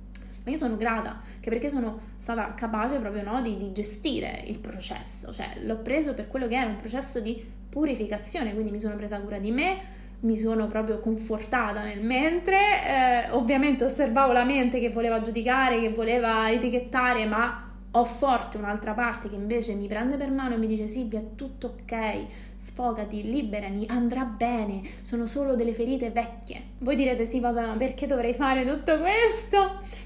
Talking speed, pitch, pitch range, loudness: 175 wpm, 235 Hz, 220-260 Hz, -27 LUFS